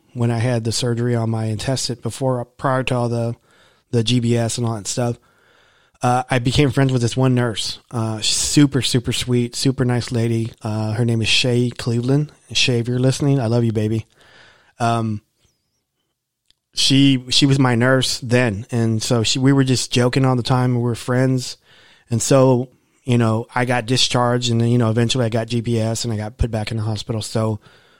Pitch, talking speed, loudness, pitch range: 120 Hz, 195 wpm, -18 LUFS, 115-130 Hz